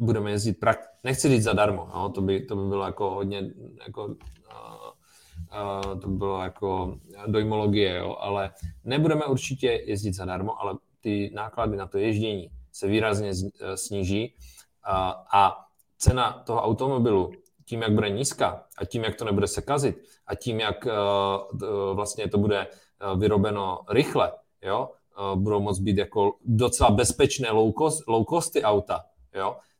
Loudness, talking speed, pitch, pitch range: -26 LUFS, 150 wpm, 105 Hz, 95-110 Hz